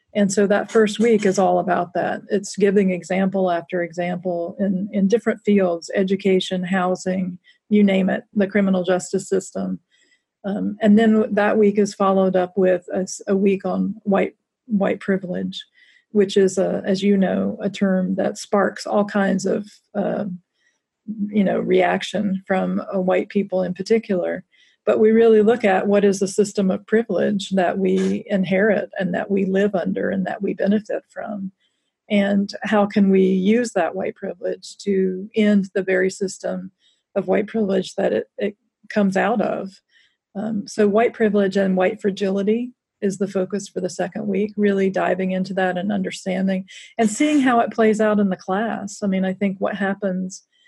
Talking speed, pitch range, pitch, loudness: 175 wpm, 190-210 Hz, 195 Hz, -20 LUFS